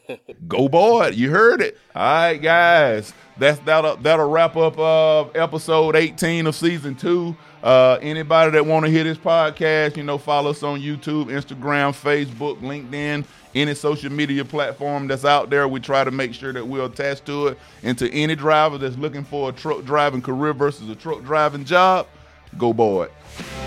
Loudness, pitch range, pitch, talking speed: -19 LUFS, 140-155 Hz, 145 Hz, 180 wpm